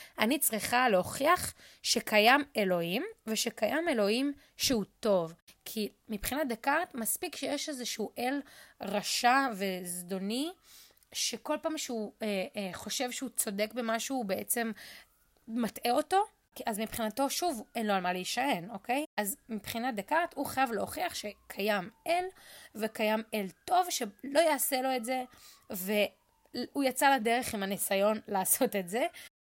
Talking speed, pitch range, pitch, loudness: 130 wpm, 210-280 Hz, 235 Hz, -31 LUFS